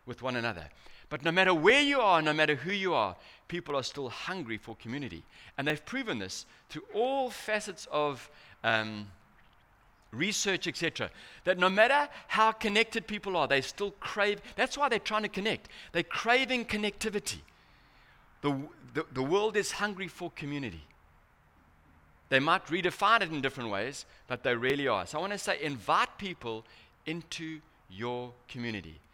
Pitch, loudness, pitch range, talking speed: 155 Hz, -30 LUFS, 120-200 Hz, 165 wpm